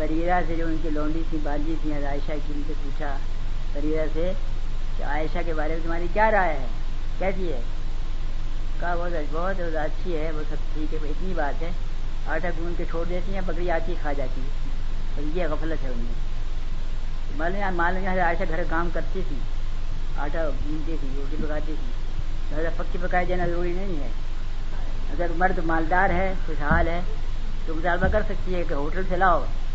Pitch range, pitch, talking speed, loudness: 135-175 Hz, 155 Hz, 185 wpm, -29 LUFS